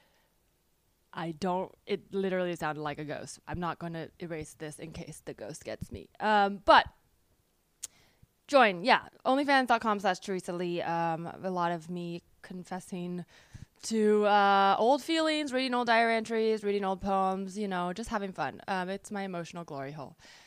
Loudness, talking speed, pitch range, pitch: -29 LUFS, 165 wpm, 170-210 Hz, 185 Hz